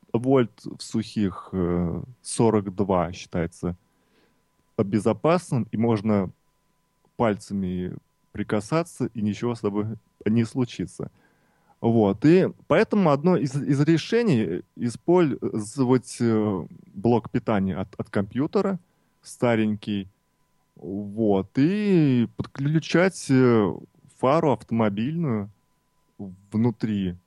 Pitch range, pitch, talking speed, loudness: 105-145 Hz, 115 Hz, 80 wpm, -24 LUFS